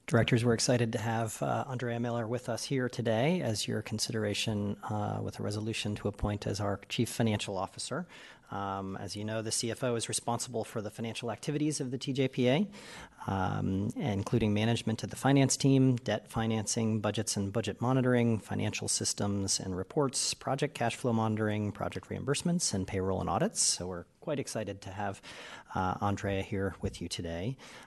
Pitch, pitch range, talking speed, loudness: 110 Hz, 100-120 Hz, 170 wpm, -32 LUFS